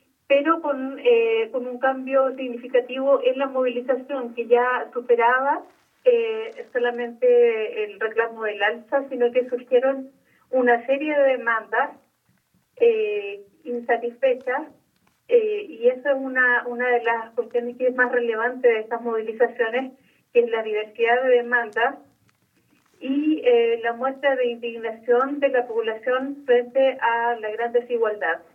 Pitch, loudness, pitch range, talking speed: 250 Hz, -22 LUFS, 235-275 Hz, 135 wpm